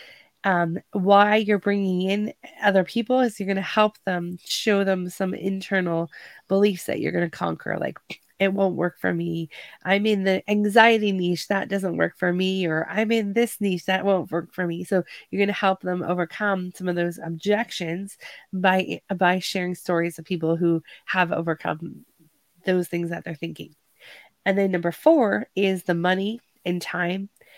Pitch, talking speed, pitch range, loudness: 185 Hz, 180 wpm, 175-200 Hz, -23 LUFS